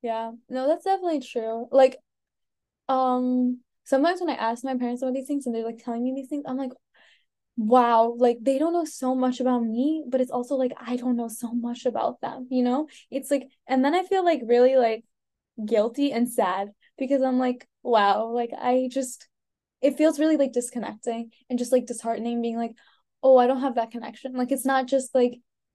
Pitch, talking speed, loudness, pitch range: 255 Hz, 205 wpm, -25 LUFS, 235-270 Hz